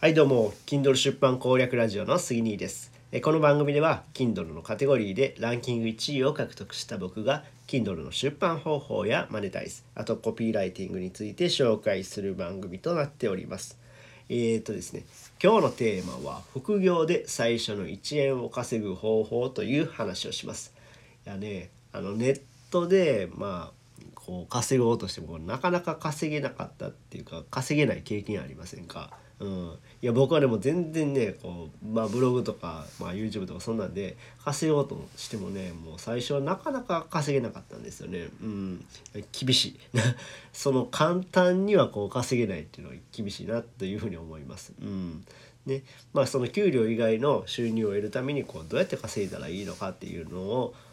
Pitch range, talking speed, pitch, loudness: 105-140 Hz, 380 characters per minute, 120 Hz, -28 LUFS